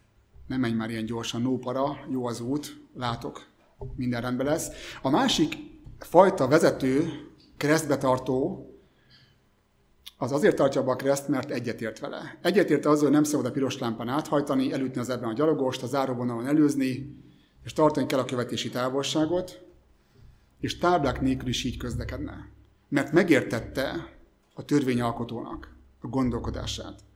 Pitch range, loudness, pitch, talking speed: 120-145 Hz, -26 LUFS, 130 Hz, 140 wpm